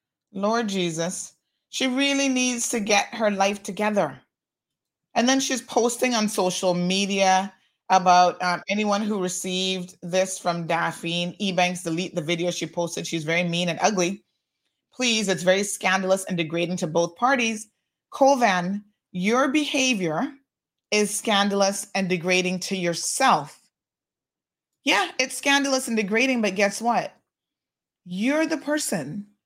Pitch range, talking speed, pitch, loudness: 180-235 Hz, 130 wpm, 195 Hz, -23 LUFS